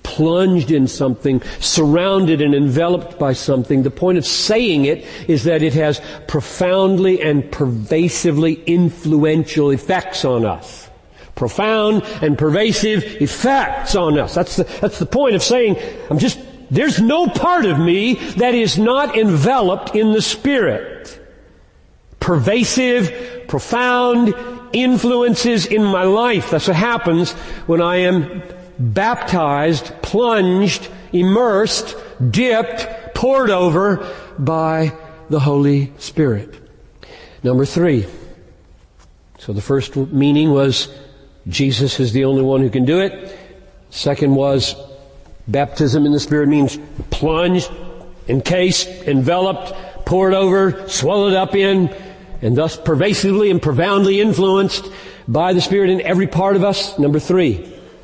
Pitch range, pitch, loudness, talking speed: 145-200 Hz, 175 Hz, -16 LUFS, 125 wpm